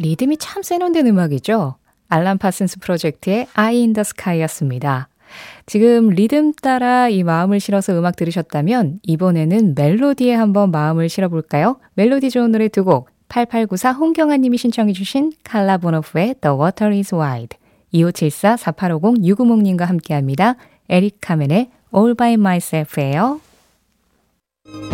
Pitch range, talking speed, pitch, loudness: 165-235 Hz, 330 characters per minute, 195 Hz, -16 LUFS